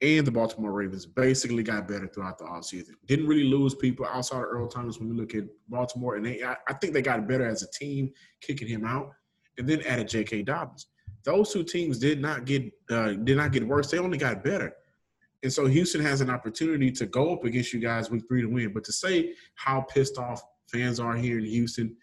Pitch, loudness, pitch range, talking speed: 125 Hz, -28 LUFS, 115-140 Hz, 230 wpm